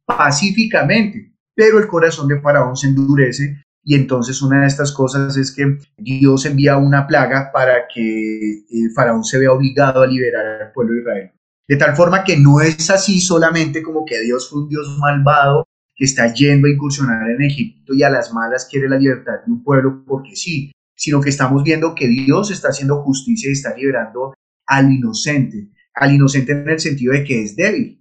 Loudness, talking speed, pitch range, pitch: -15 LUFS, 190 wpm, 130-150 Hz, 140 Hz